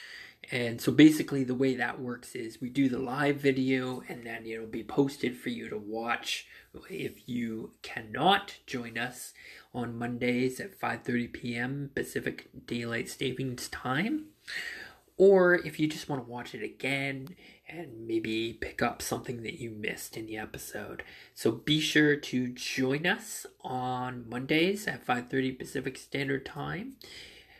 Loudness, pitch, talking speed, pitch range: -31 LUFS, 130 Hz, 150 wpm, 120-150 Hz